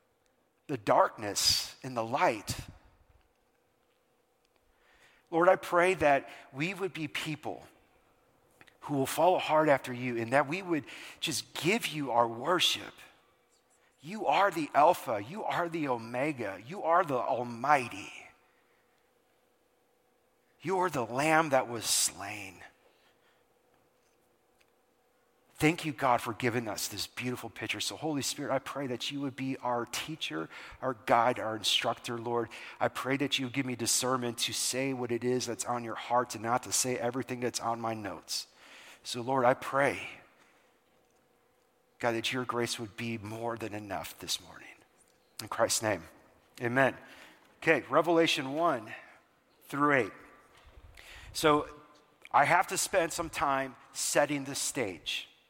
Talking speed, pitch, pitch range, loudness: 145 wpm, 130 Hz, 120-155 Hz, -31 LUFS